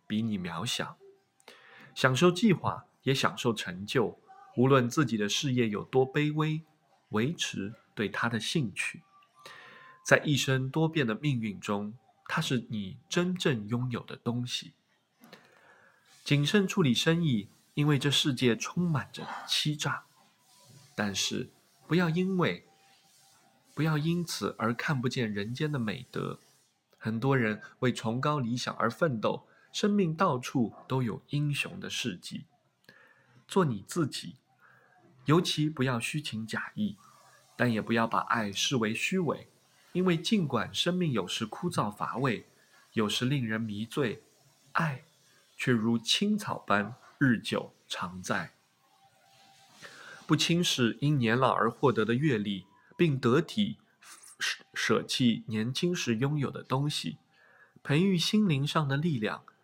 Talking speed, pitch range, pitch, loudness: 190 characters per minute, 115-165 Hz, 135 Hz, -30 LUFS